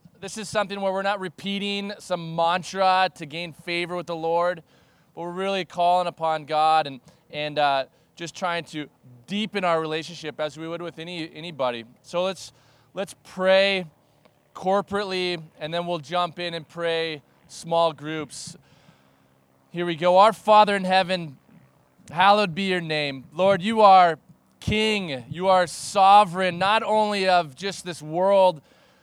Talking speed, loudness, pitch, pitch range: 155 wpm, -23 LUFS, 175 Hz, 155-190 Hz